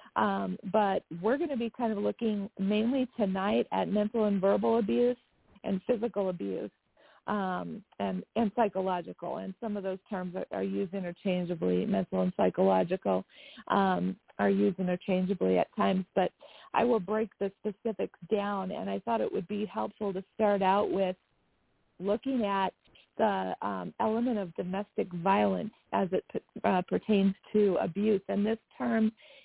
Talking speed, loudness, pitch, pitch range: 155 wpm, -31 LUFS, 200 Hz, 185-220 Hz